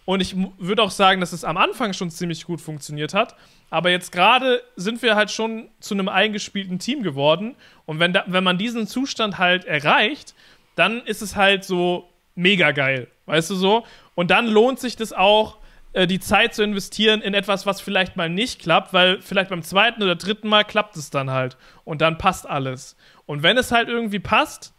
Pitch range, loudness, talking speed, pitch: 175-215 Hz, -20 LUFS, 200 wpm, 190 Hz